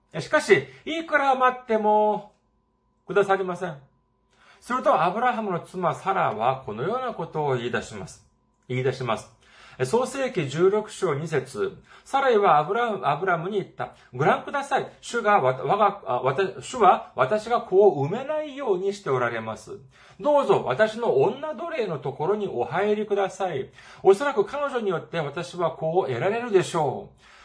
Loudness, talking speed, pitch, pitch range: -24 LUFS, 310 characters per minute, 200 Hz, 170-255 Hz